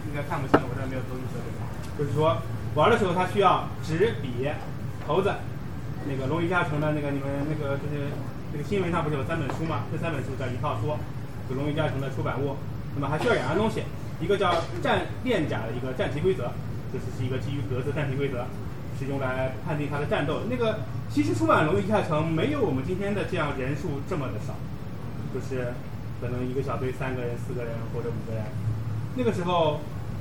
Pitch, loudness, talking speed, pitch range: 135 Hz, -28 LUFS, 330 characters per minute, 125-150 Hz